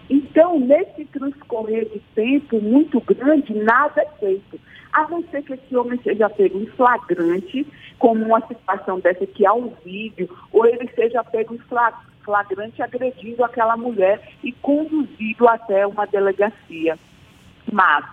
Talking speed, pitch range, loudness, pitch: 140 wpm, 205-275 Hz, -19 LUFS, 230 Hz